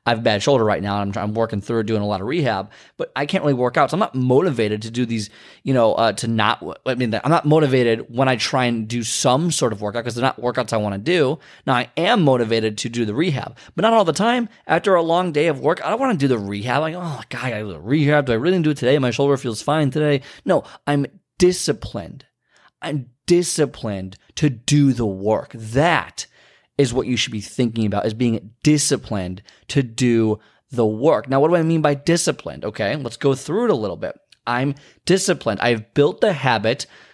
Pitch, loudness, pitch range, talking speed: 130 Hz, -20 LUFS, 110-150 Hz, 240 wpm